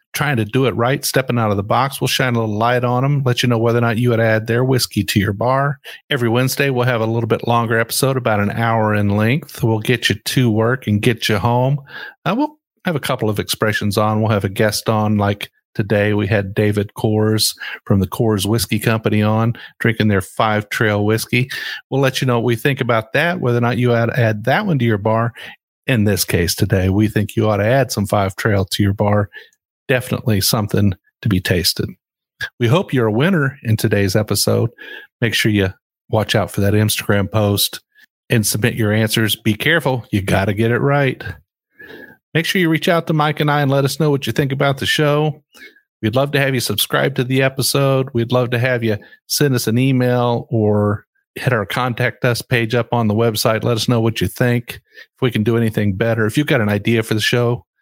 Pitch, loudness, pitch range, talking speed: 115 Hz, -17 LUFS, 105-130 Hz, 230 wpm